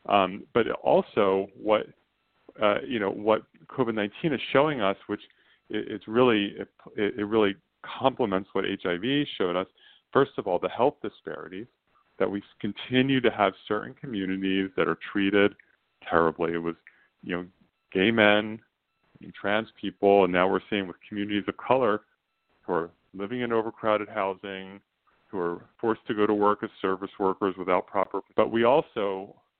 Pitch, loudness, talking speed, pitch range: 100 Hz, -27 LUFS, 165 wpm, 95-110 Hz